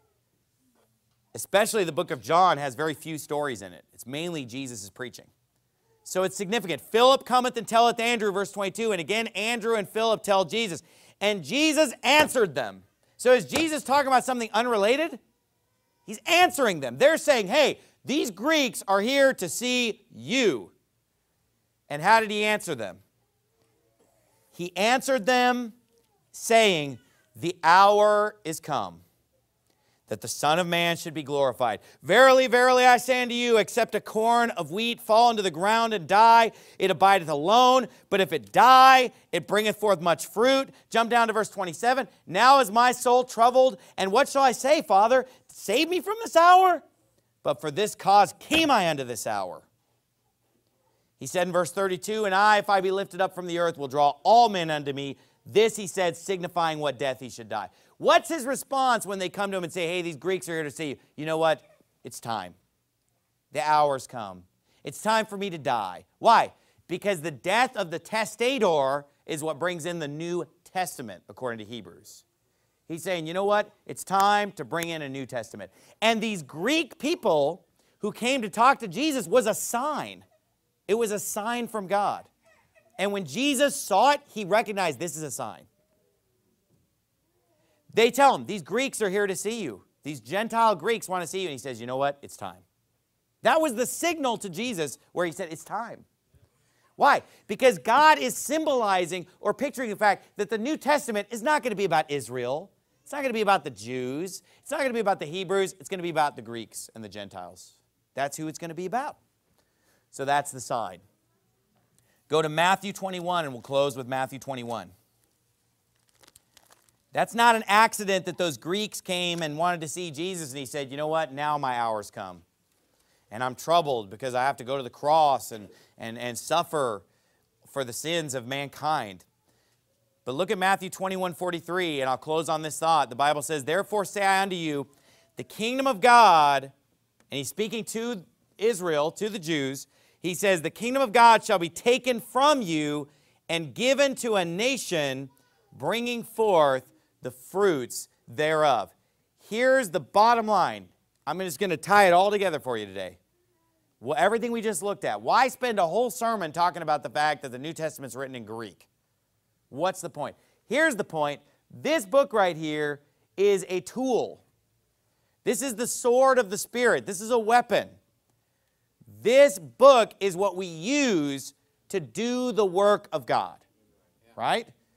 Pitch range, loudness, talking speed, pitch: 145-230 Hz, -24 LUFS, 185 wpm, 190 Hz